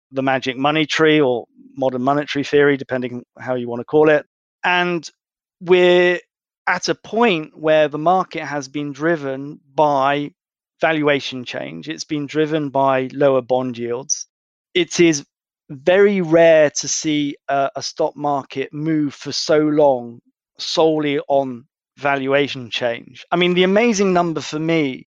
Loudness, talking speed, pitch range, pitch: -18 LUFS, 145 wpm, 135-160 Hz, 150 Hz